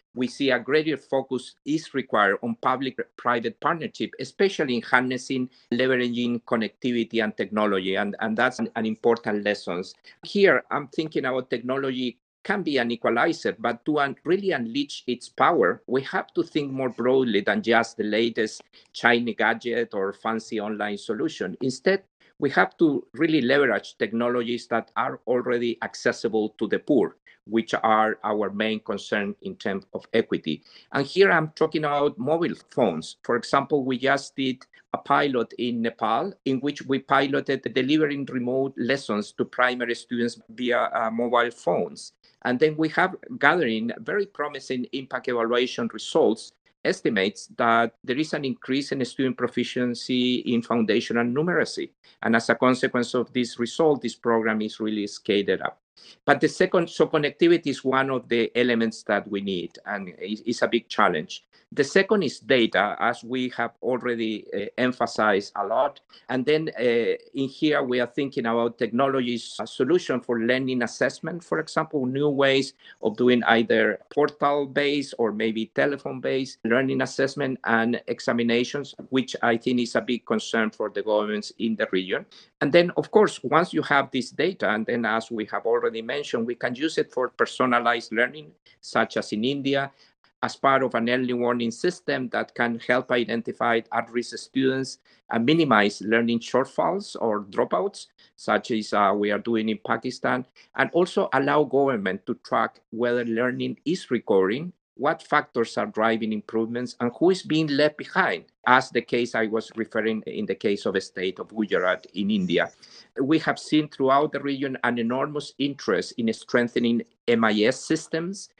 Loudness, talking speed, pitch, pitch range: -24 LUFS, 165 wpm, 125 Hz, 115-140 Hz